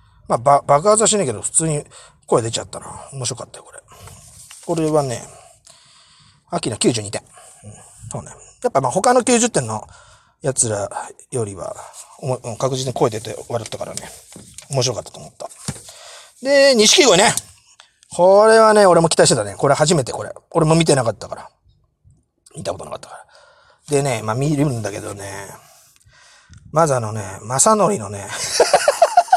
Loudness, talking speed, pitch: -17 LUFS, 285 characters per minute, 150 Hz